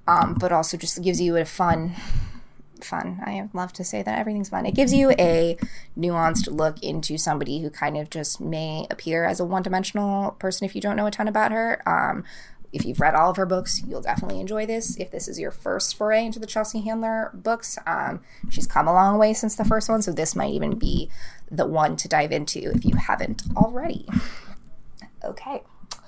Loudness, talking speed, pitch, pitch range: -24 LUFS, 210 wpm, 190 Hz, 170-215 Hz